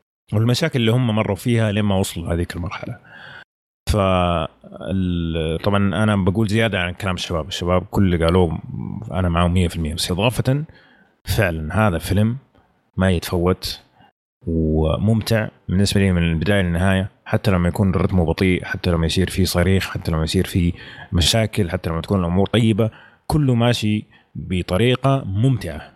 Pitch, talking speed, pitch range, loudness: 95 Hz, 140 wpm, 85-110 Hz, -20 LUFS